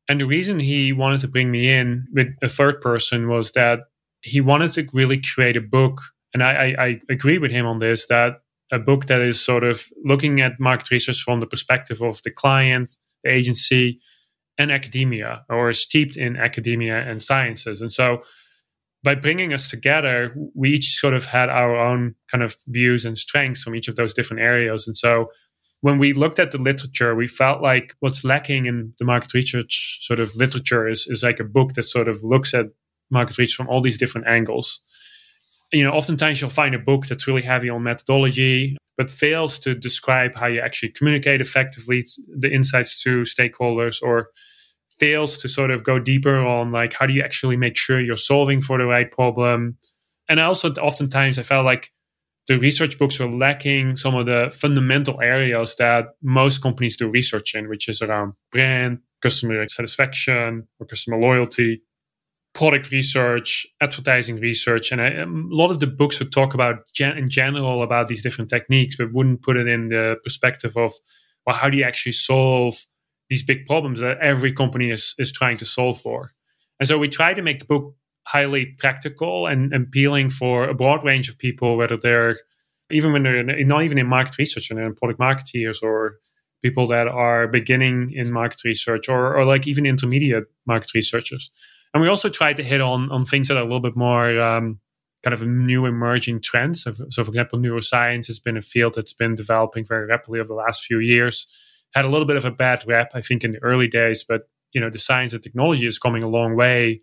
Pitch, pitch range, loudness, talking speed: 125 Hz, 120-135 Hz, -19 LUFS, 200 wpm